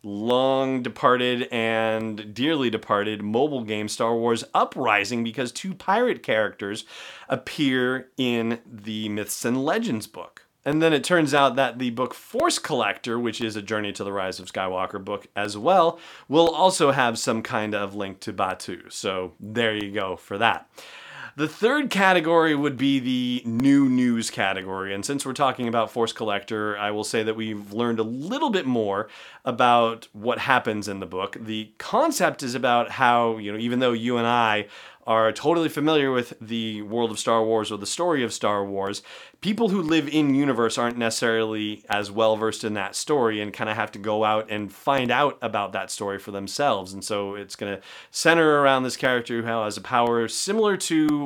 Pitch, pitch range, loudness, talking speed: 115 Hz, 105-130 Hz, -24 LUFS, 185 wpm